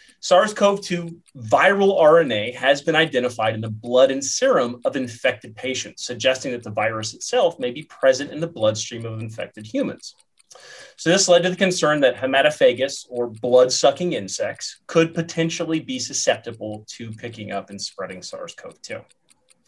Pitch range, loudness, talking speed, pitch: 115-165 Hz, -20 LUFS, 165 wpm, 130 Hz